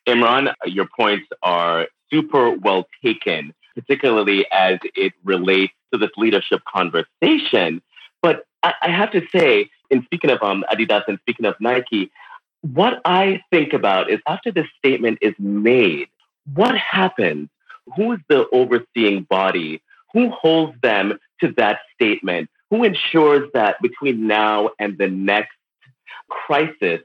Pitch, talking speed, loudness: 130 Hz, 135 wpm, -18 LUFS